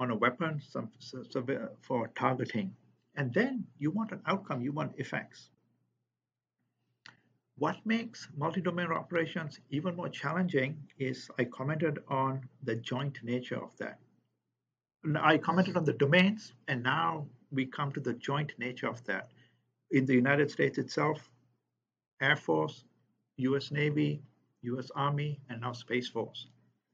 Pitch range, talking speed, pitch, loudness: 125-160 Hz, 140 wpm, 140 Hz, -33 LUFS